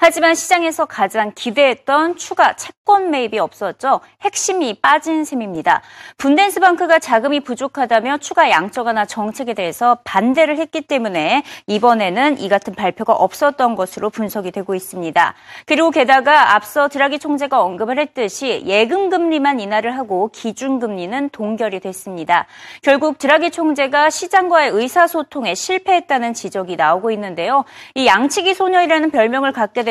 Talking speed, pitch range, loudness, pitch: 360 characters per minute, 215-315 Hz, -16 LUFS, 270 Hz